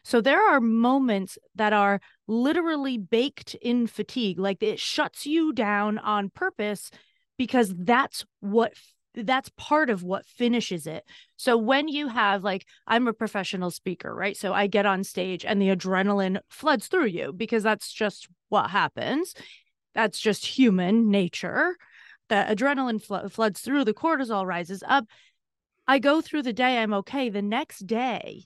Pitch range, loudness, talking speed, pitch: 200-260 Hz, -25 LUFS, 160 wpm, 220 Hz